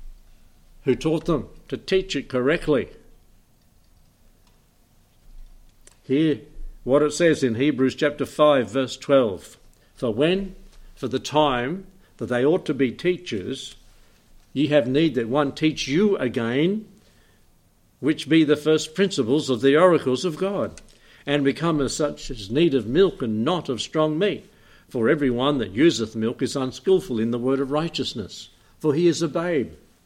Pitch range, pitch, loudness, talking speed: 120-155 Hz, 140 Hz, -22 LUFS, 155 wpm